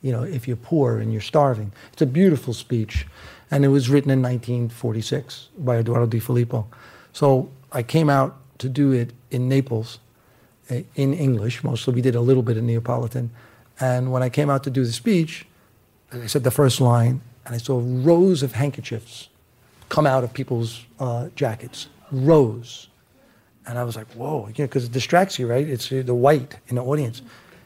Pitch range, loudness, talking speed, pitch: 115-135 Hz, -22 LUFS, 190 wpm, 125 Hz